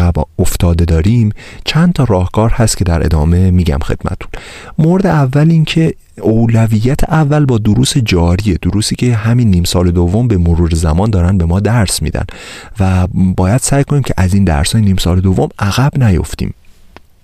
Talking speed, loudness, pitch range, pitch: 170 wpm, -12 LUFS, 90-120 Hz, 100 Hz